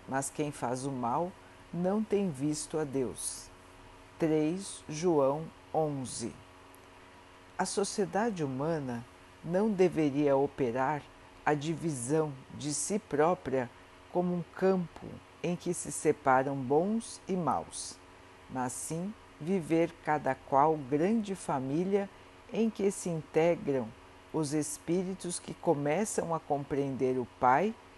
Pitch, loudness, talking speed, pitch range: 150 Hz, -32 LUFS, 115 wpm, 125-175 Hz